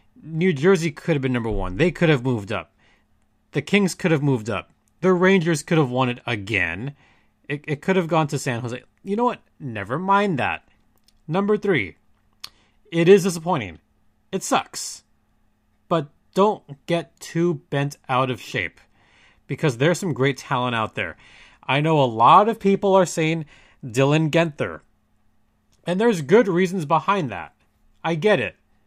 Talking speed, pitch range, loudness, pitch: 165 wpm, 105-175 Hz, -21 LUFS, 140 Hz